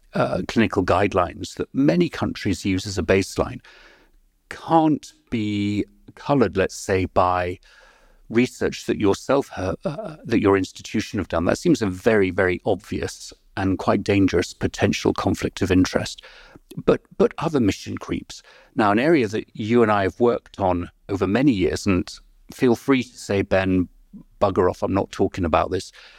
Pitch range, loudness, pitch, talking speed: 95-110 Hz, -22 LUFS, 100 Hz, 160 wpm